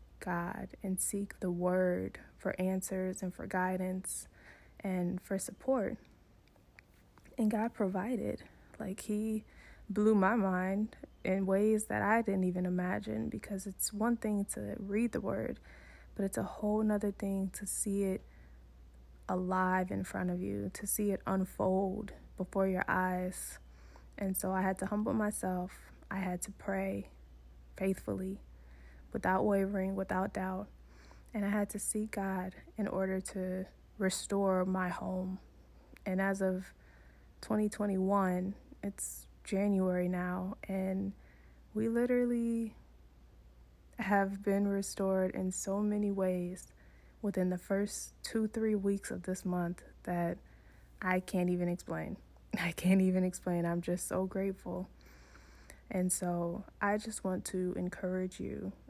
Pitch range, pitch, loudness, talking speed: 180-200 Hz, 190 Hz, -35 LUFS, 135 wpm